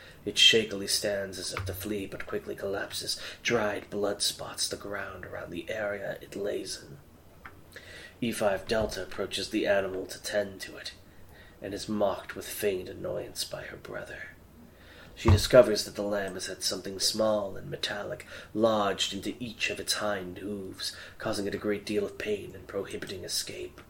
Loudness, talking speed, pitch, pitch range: -30 LUFS, 170 wpm, 100 Hz, 95-105 Hz